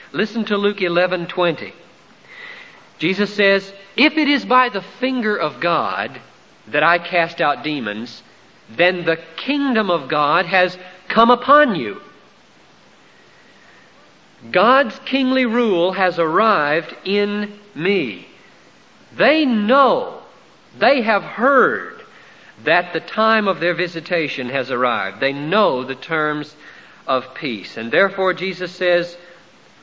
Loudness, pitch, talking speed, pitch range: -17 LUFS, 185 Hz, 120 wpm, 170-225 Hz